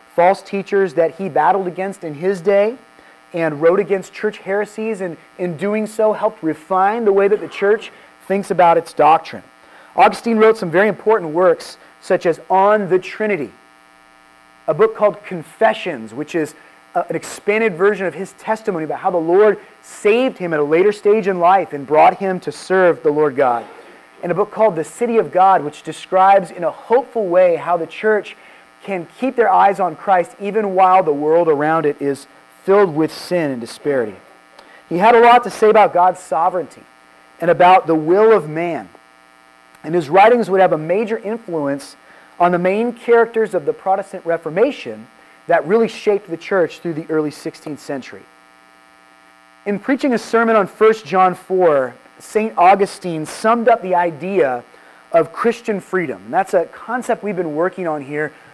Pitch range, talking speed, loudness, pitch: 155-205 Hz, 180 wpm, -16 LUFS, 185 Hz